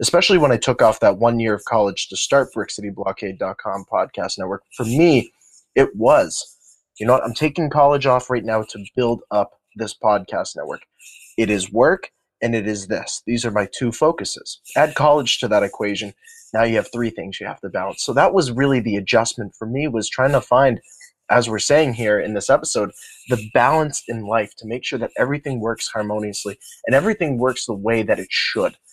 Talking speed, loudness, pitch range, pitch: 205 wpm, -19 LUFS, 110-145 Hz, 120 Hz